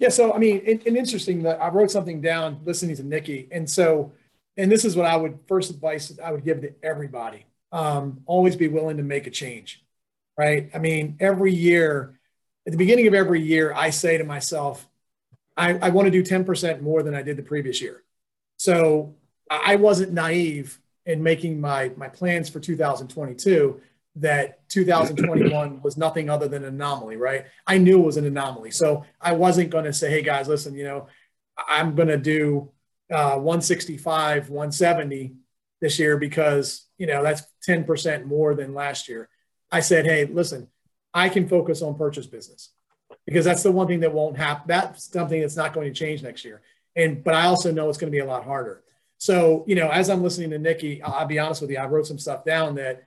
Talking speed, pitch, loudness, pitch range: 205 wpm, 155 Hz, -22 LUFS, 145-175 Hz